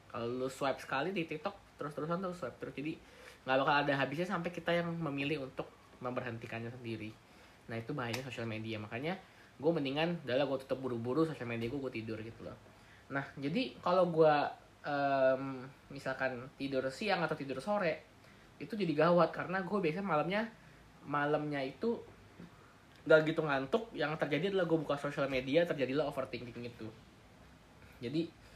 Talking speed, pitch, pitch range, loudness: 160 wpm, 140 Hz, 120-160 Hz, -35 LUFS